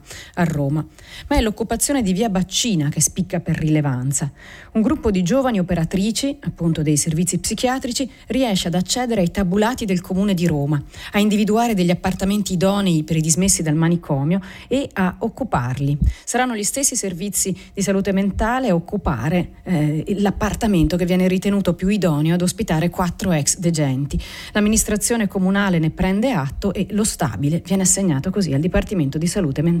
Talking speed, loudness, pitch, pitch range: 160 wpm, -19 LUFS, 185 Hz, 165-210 Hz